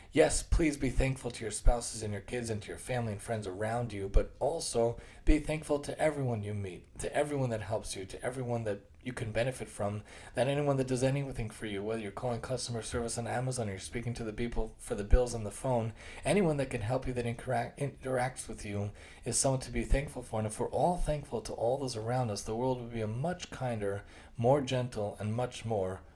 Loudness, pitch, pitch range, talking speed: -34 LUFS, 120 Hz, 105-130 Hz, 235 wpm